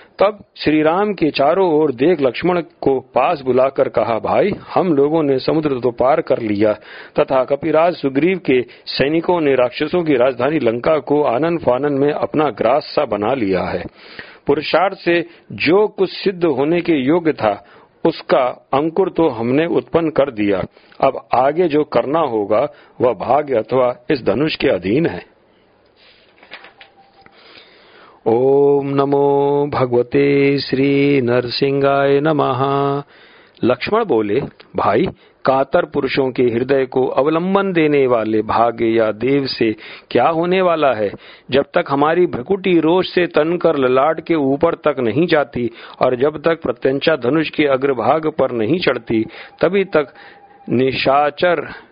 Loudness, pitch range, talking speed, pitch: -16 LUFS, 130-165 Hz, 140 wpm, 140 Hz